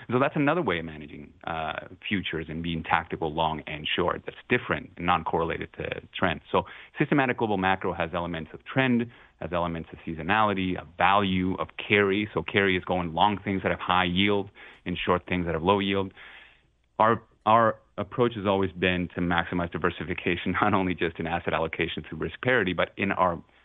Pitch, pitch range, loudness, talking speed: 90 Hz, 85-100 Hz, -27 LUFS, 190 wpm